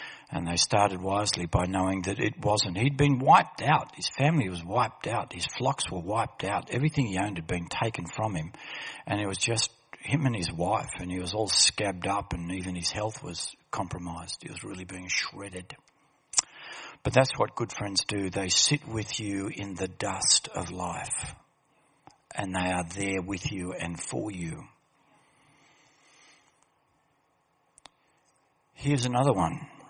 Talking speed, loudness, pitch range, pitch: 165 wpm, -28 LUFS, 90-115 Hz, 100 Hz